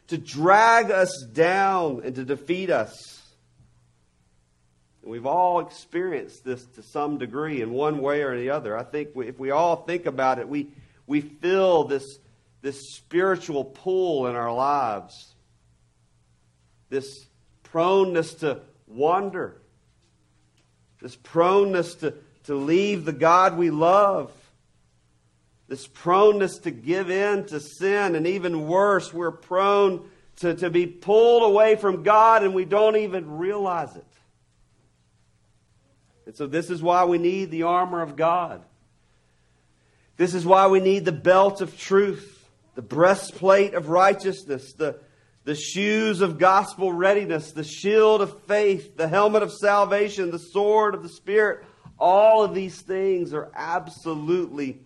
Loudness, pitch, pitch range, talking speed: -22 LUFS, 170 Hz, 135-195 Hz, 140 wpm